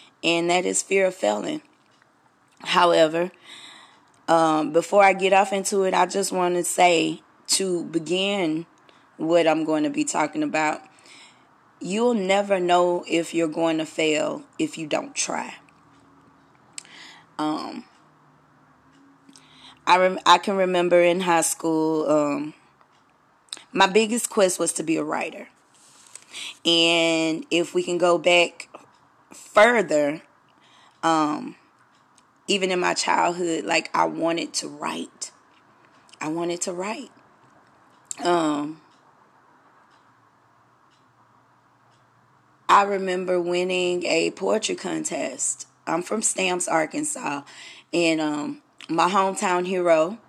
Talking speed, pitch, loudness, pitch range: 115 wpm, 175 Hz, -22 LUFS, 160-190 Hz